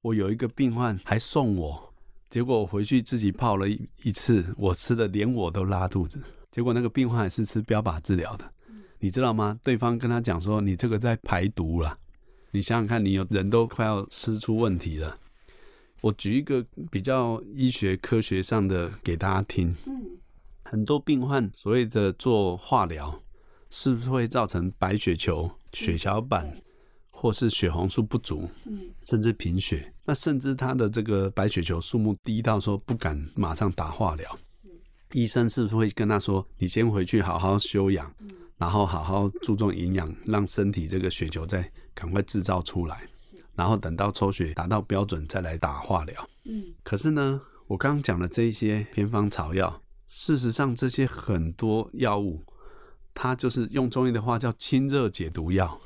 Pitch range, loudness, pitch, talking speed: 95-120 Hz, -27 LUFS, 105 Hz, 255 characters per minute